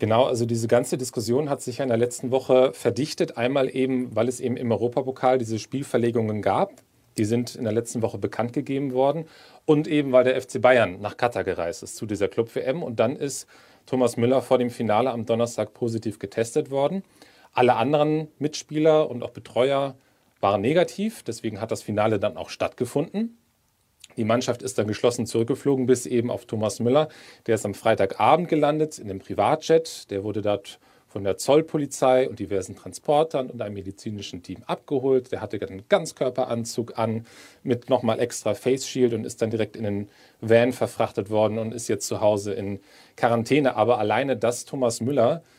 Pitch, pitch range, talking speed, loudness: 125 Hz, 110-135 Hz, 180 wpm, -24 LUFS